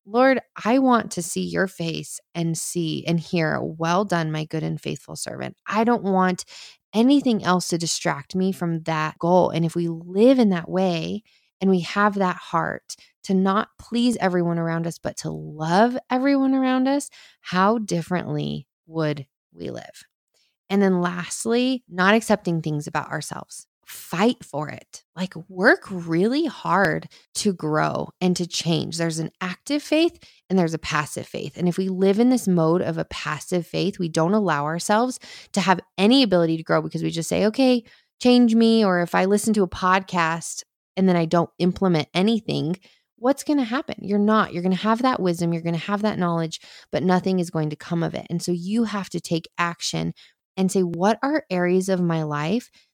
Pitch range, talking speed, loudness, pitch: 165-215 Hz, 190 wpm, -22 LUFS, 185 Hz